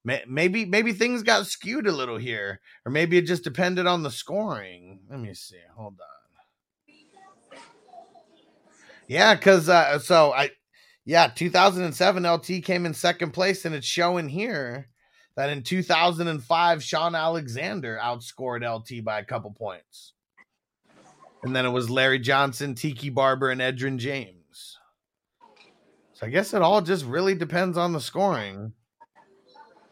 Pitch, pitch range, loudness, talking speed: 165 Hz, 125-190 Hz, -23 LUFS, 140 wpm